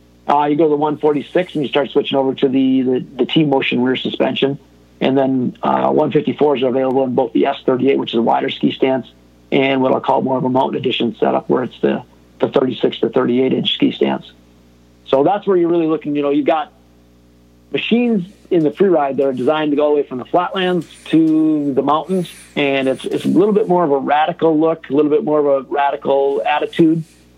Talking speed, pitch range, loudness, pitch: 220 wpm, 125-155 Hz, -16 LUFS, 140 Hz